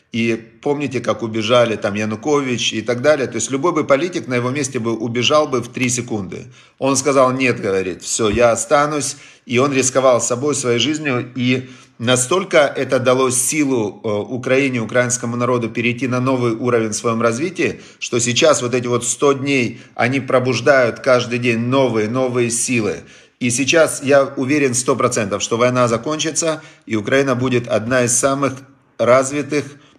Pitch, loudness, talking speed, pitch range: 125 Hz, -17 LUFS, 160 wpm, 120-140 Hz